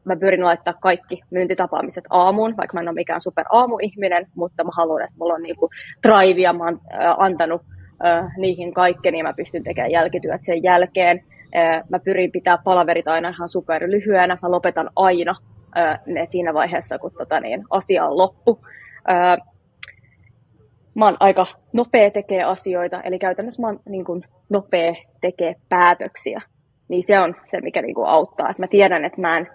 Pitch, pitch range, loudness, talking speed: 180 Hz, 170-185 Hz, -19 LUFS, 175 wpm